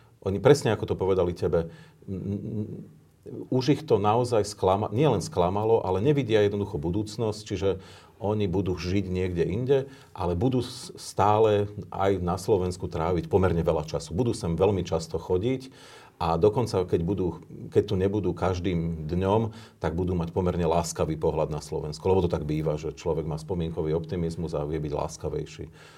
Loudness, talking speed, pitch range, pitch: -27 LUFS, 165 wpm, 85-110 Hz, 95 Hz